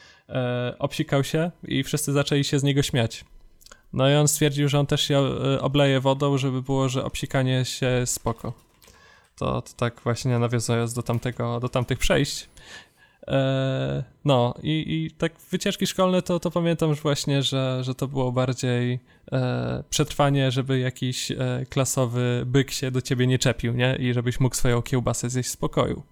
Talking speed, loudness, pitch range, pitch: 160 wpm, -24 LUFS, 125-145 Hz, 130 Hz